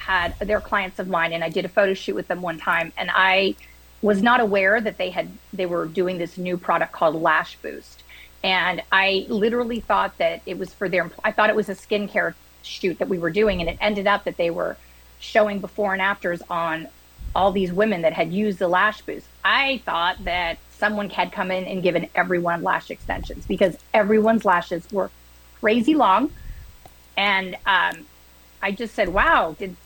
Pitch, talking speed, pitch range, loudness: 190 Hz, 195 wpm, 170-210 Hz, -22 LUFS